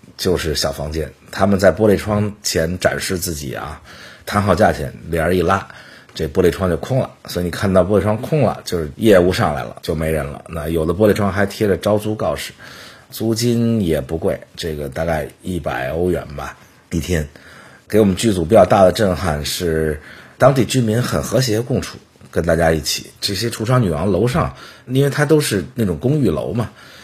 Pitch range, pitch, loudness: 80-110 Hz, 95 Hz, -18 LUFS